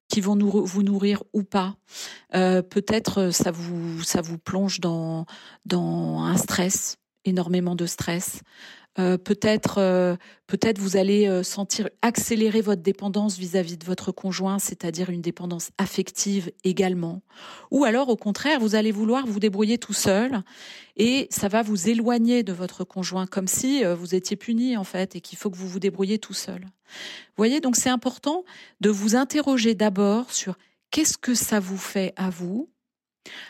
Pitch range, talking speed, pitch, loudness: 185-220 Hz, 175 wpm, 200 Hz, -24 LUFS